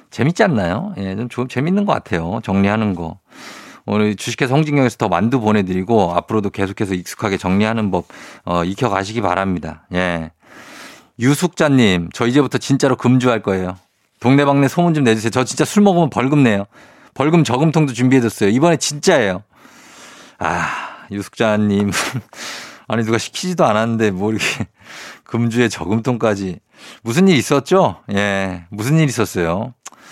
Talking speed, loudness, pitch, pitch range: 340 characters per minute, -17 LUFS, 110 Hz, 100-135 Hz